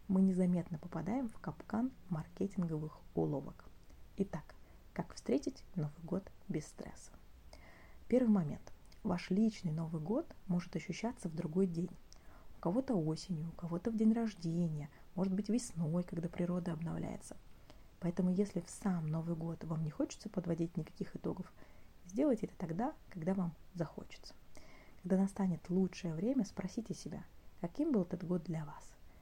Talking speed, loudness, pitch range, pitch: 140 wpm, -39 LUFS, 165-200 Hz, 180 Hz